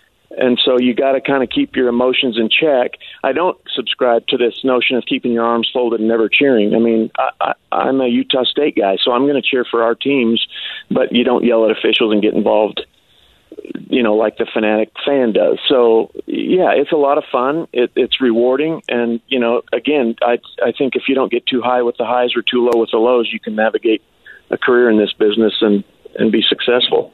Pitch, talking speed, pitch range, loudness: 120 Hz, 220 wpm, 115-135 Hz, -15 LUFS